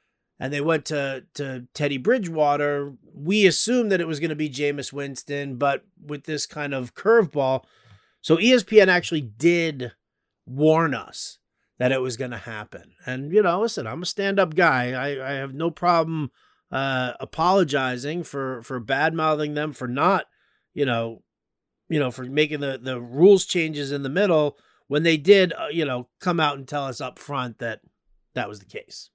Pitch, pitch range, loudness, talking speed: 145 Hz, 130-165 Hz, -23 LUFS, 180 wpm